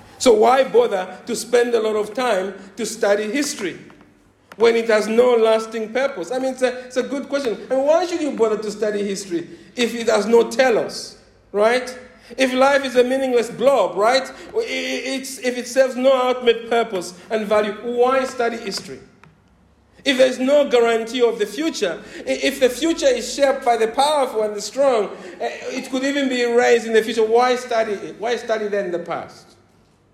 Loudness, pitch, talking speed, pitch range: -19 LUFS, 240 Hz, 185 wpm, 220-265 Hz